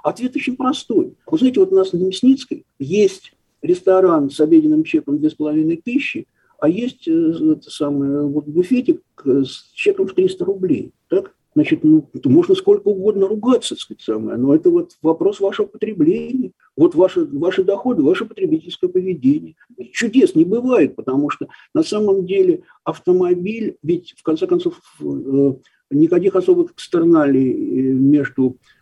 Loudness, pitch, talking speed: -17 LUFS, 255 Hz, 140 wpm